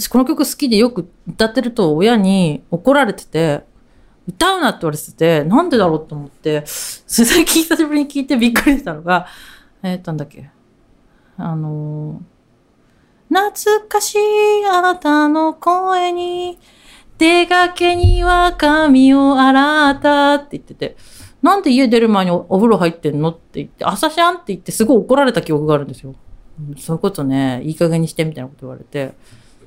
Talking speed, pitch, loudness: 330 characters per minute, 230 Hz, -14 LUFS